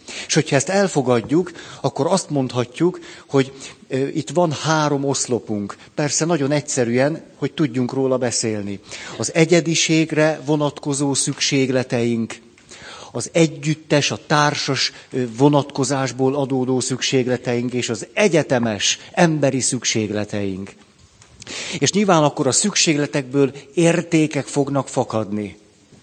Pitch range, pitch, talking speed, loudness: 125-155 Hz, 140 Hz, 100 wpm, -19 LUFS